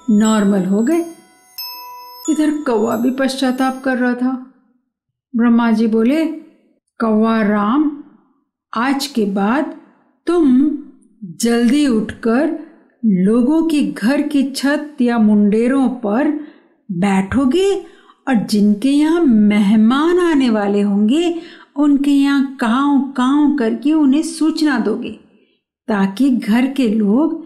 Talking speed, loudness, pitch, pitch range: 105 wpm, -15 LUFS, 265 Hz, 225-300 Hz